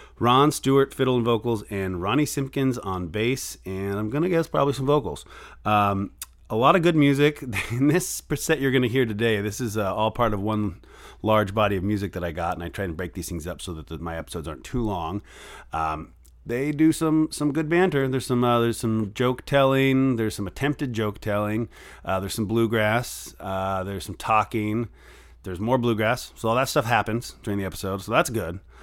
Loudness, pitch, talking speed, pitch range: -24 LUFS, 110 Hz, 210 wpm, 100-135 Hz